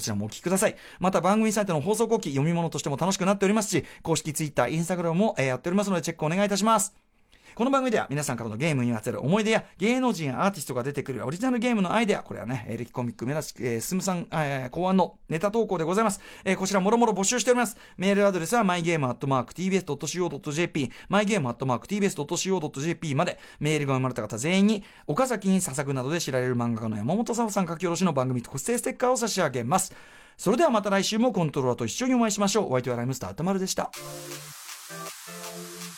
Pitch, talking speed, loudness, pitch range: 175 Hz, 505 characters per minute, -26 LUFS, 135-205 Hz